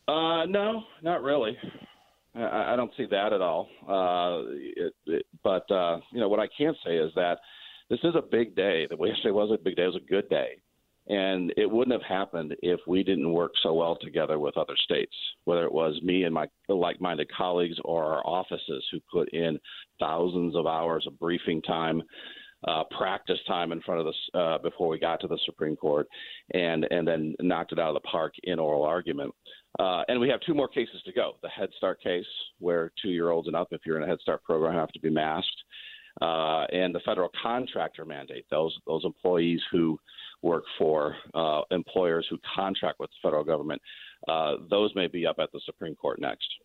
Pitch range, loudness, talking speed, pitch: 80-105 Hz, -29 LUFS, 210 wpm, 90 Hz